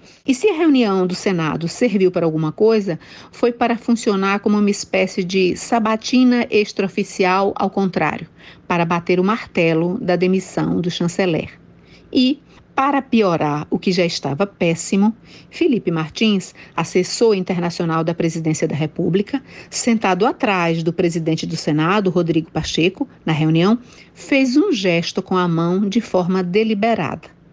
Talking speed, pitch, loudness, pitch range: 140 wpm, 190 Hz, -18 LUFS, 170-220 Hz